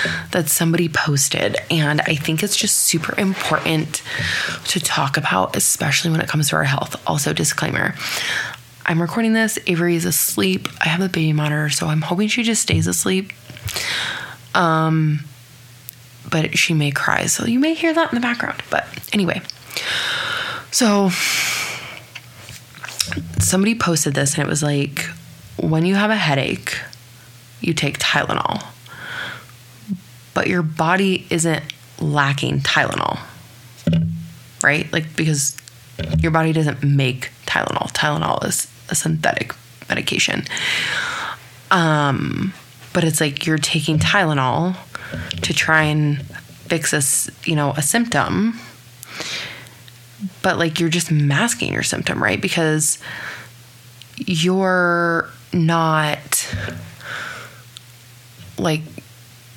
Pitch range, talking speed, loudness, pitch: 130-175 Hz, 120 wpm, -19 LUFS, 155 Hz